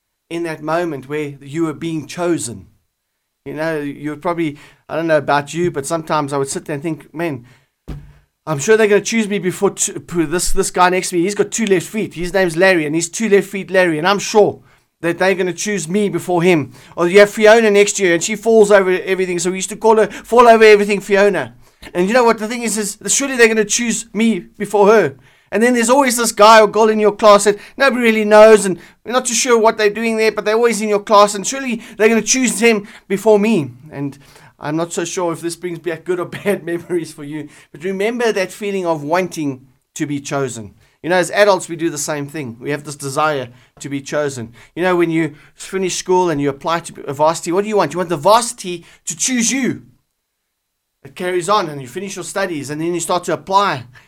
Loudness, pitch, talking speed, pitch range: -15 LUFS, 180 Hz, 245 wpm, 155-210 Hz